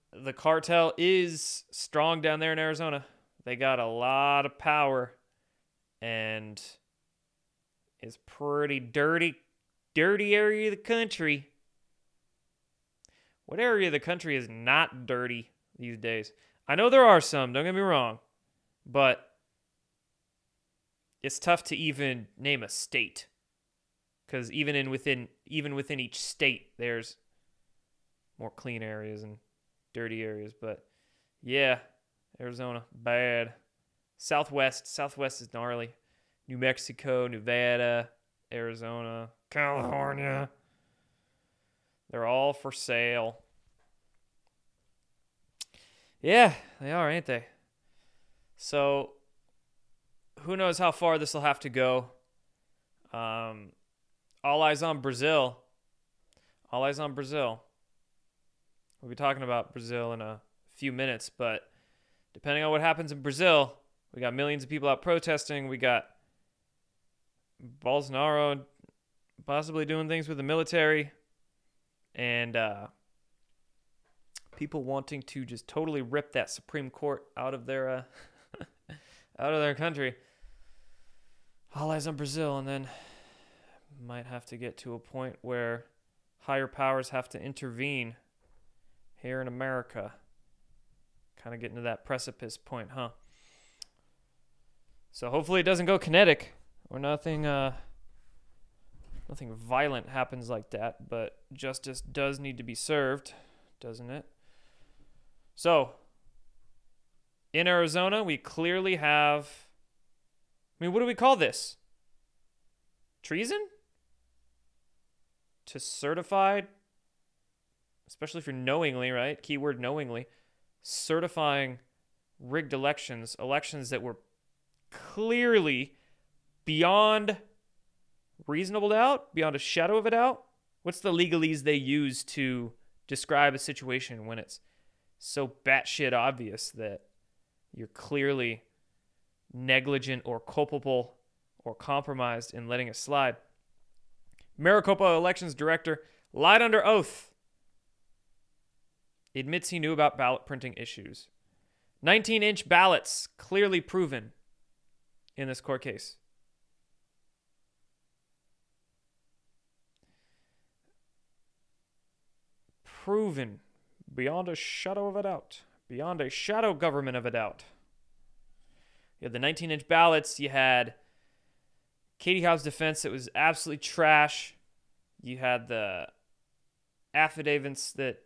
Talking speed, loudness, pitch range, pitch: 110 wpm, -29 LUFS, 120-155 Hz, 140 Hz